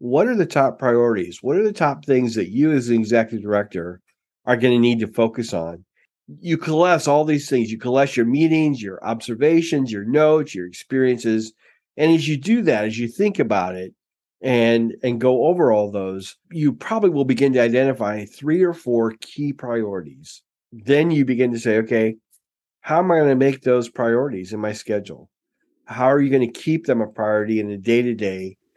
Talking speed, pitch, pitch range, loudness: 195 wpm, 120 Hz, 110-145 Hz, -19 LUFS